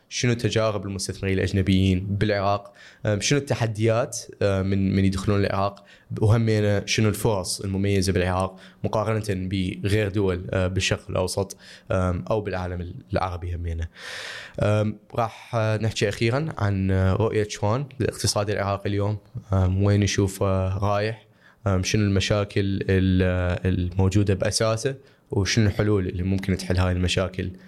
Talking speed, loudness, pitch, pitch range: 105 wpm, -24 LUFS, 100 Hz, 95-105 Hz